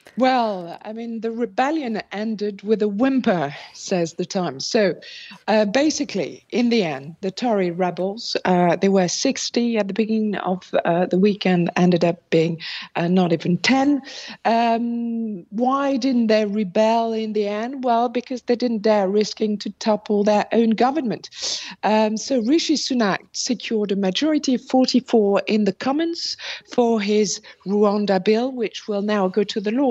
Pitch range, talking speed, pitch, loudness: 195-240 Hz, 165 wpm, 215 Hz, -21 LUFS